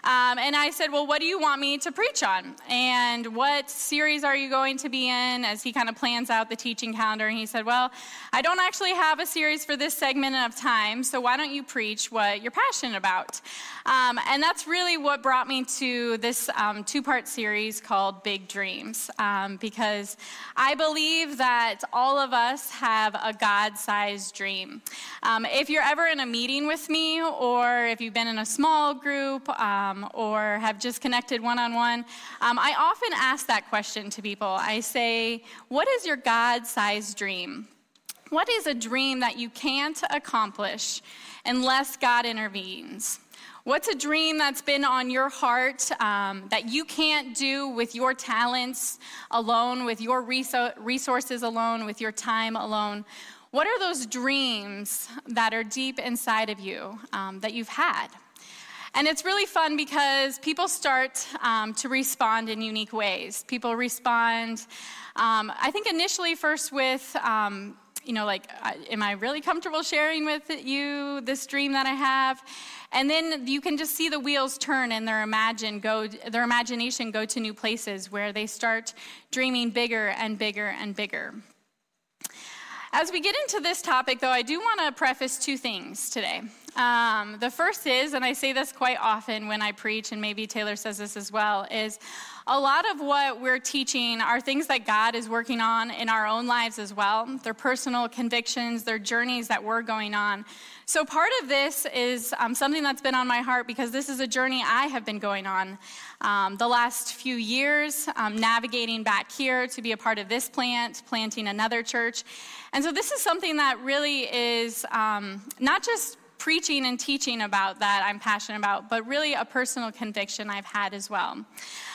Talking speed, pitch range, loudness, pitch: 185 wpm, 220-275 Hz, -26 LUFS, 245 Hz